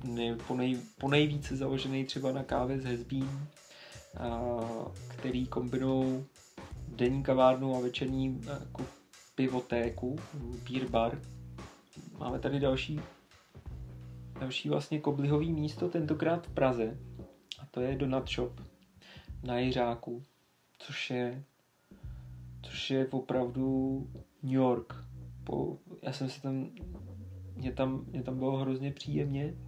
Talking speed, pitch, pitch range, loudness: 120 wpm, 130 Hz, 115-135 Hz, -34 LUFS